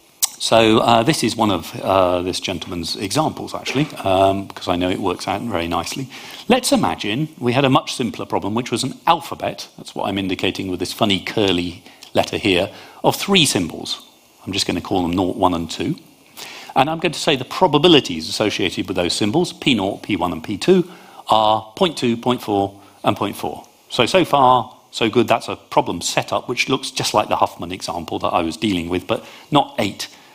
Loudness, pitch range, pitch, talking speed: -19 LUFS, 95-135 Hz, 115 Hz, 195 wpm